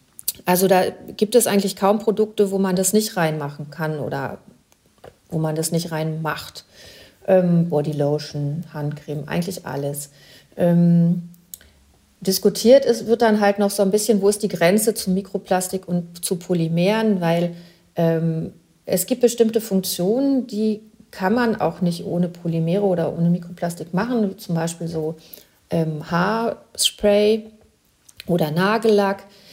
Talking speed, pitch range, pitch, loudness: 140 wpm, 165-205 Hz, 180 Hz, -20 LUFS